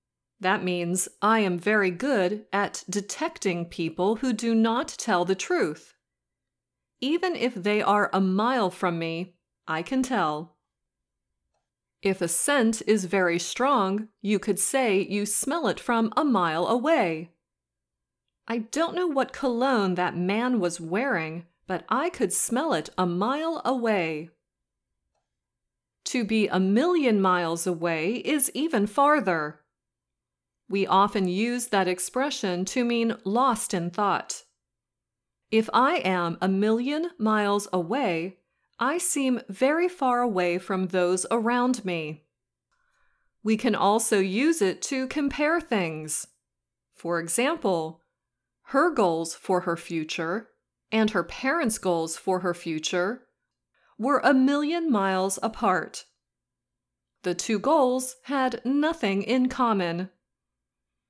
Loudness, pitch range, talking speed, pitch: -25 LUFS, 180-250 Hz, 125 wpm, 205 Hz